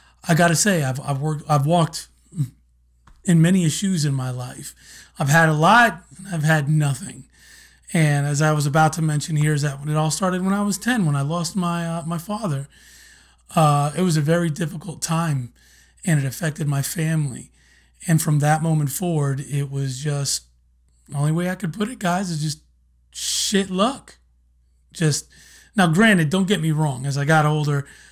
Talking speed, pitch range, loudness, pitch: 190 wpm, 140-170 Hz, -21 LUFS, 155 Hz